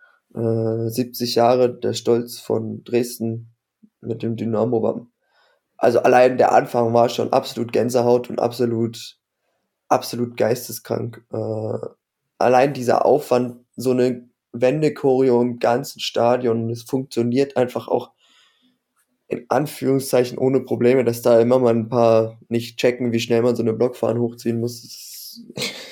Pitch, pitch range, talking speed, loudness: 120 Hz, 115-125 Hz, 130 wpm, -20 LUFS